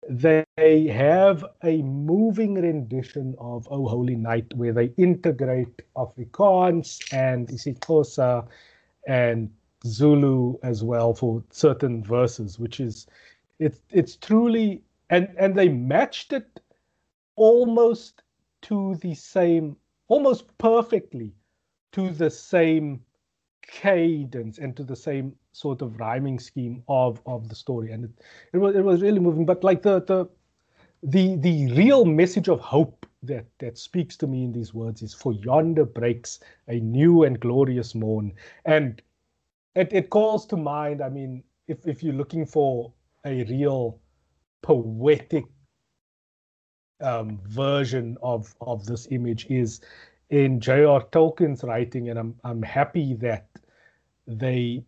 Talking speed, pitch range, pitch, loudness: 135 wpm, 120-165 Hz, 135 Hz, -23 LUFS